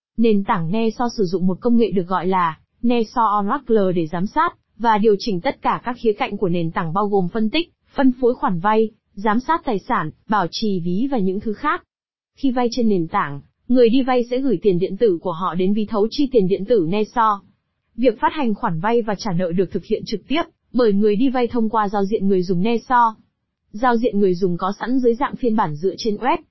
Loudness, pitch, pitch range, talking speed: -20 LUFS, 215 Hz, 195-245 Hz, 240 wpm